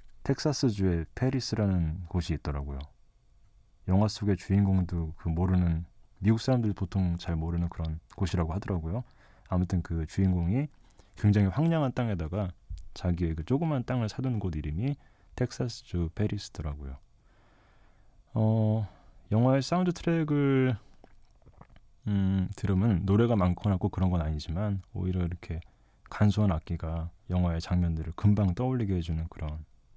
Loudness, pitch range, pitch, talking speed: -30 LUFS, 85-110 Hz, 95 Hz, 310 characters per minute